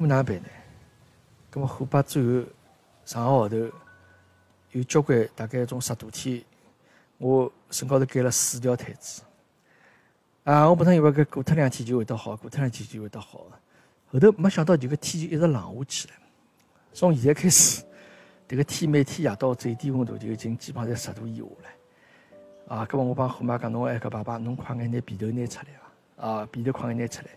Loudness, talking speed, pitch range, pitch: -25 LUFS, 285 characters per minute, 115-145 Hz, 125 Hz